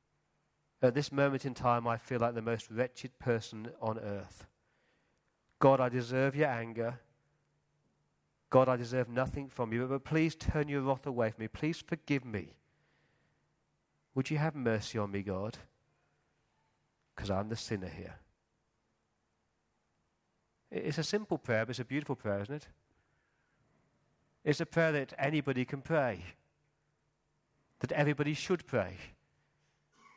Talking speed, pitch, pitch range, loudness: 140 wpm, 130 Hz, 115-145 Hz, -34 LUFS